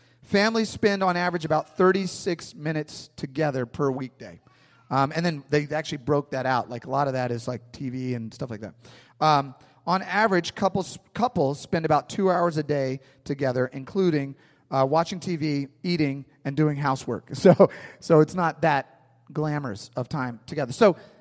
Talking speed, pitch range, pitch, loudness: 170 wpm, 130-175 Hz, 150 Hz, -25 LUFS